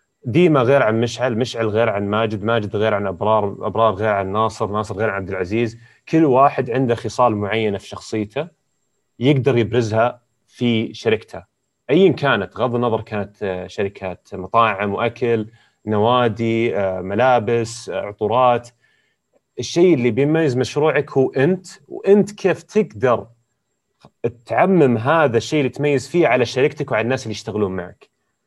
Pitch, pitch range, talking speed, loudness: 115 Hz, 105-130 Hz, 135 wpm, -18 LUFS